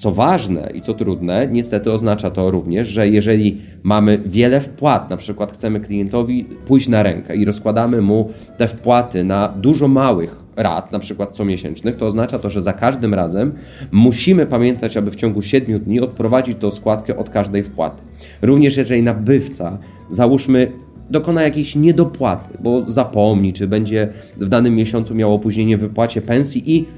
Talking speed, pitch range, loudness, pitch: 160 wpm, 105-125 Hz, -16 LUFS, 110 Hz